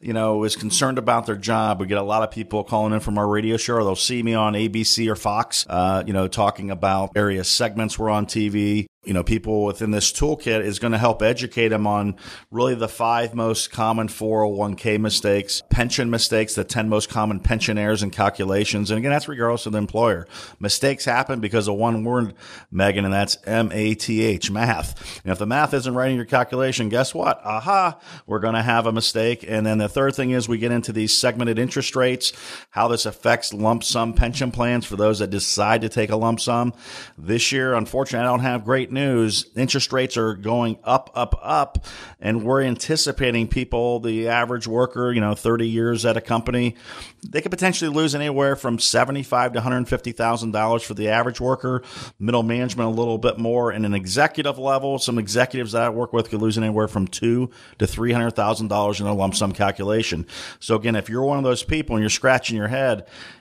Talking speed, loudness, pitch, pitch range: 205 wpm, -21 LUFS, 115 Hz, 105-125 Hz